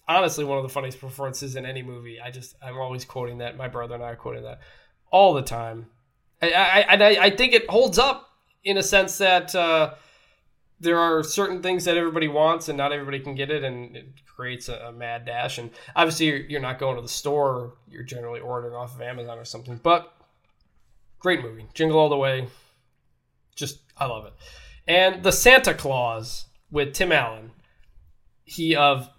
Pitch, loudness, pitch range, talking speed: 135 Hz, -21 LUFS, 120-165 Hz, 195 wpm